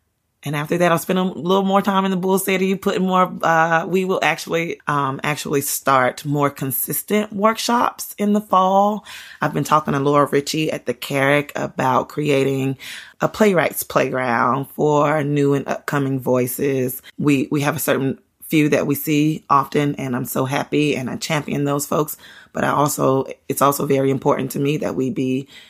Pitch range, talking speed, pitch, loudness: 135-175 Hz, 180 wpm, 145 Hz, -19 LUFS